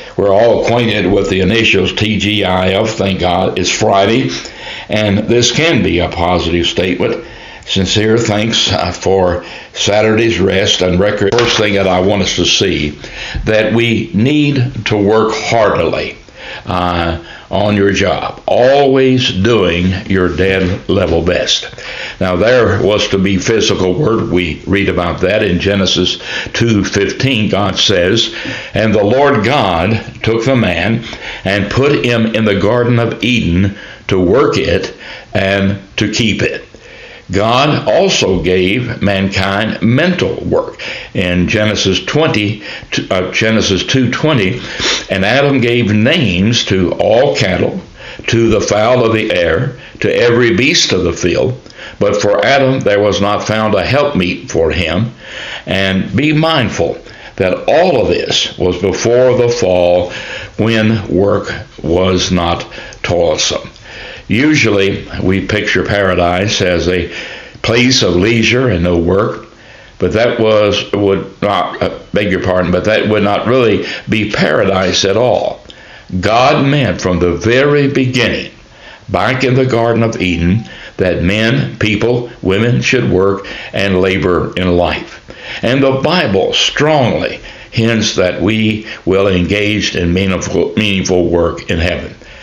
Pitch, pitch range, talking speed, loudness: 105 Hz, 95-115 Hz, 140 wpm, -12 LUFS